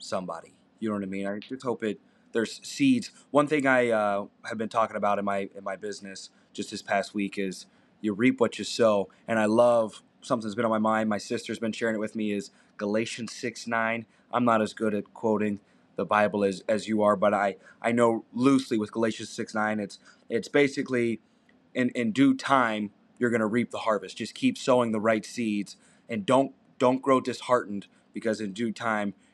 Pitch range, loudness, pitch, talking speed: 105-120 Hz, -27 LUFS, 110 Hz, 210 wpm